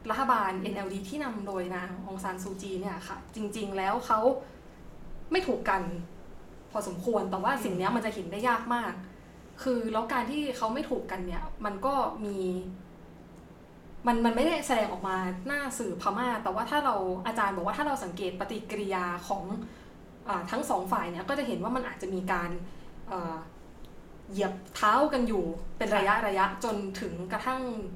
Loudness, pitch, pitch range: -31 LUFS, 205 Hz, 185-240 Hz